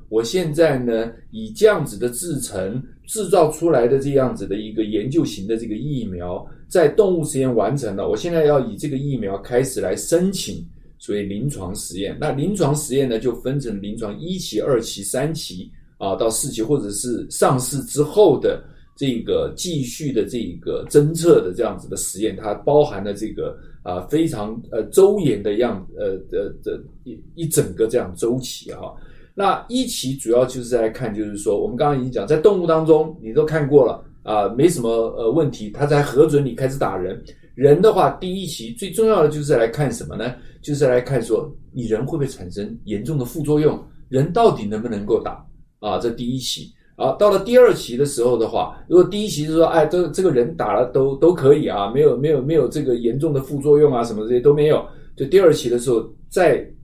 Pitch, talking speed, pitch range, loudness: 145 Hz, 300 characters per minute, 120-165 Hz, -19 LUFS